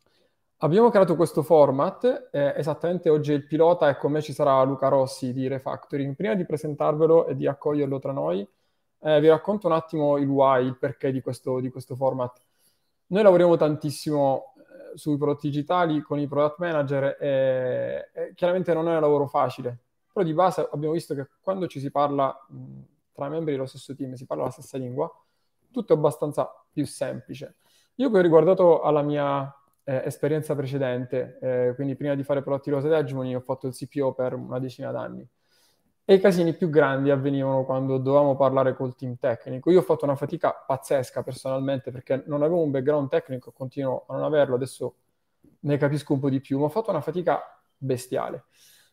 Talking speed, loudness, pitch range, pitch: 190 wpm, -24 LUFS, 135-160 Hz, 145 Hz